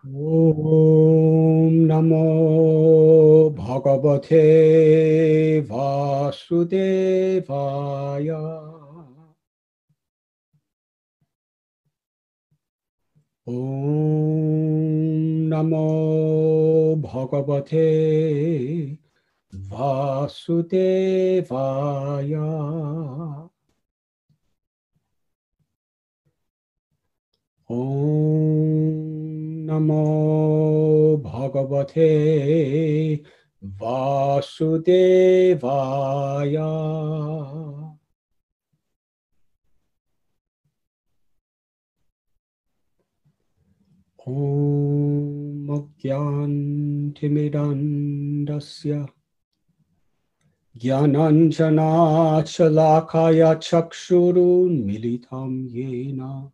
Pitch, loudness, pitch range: 155 Hz, -19 LUFS, 140-160 Hz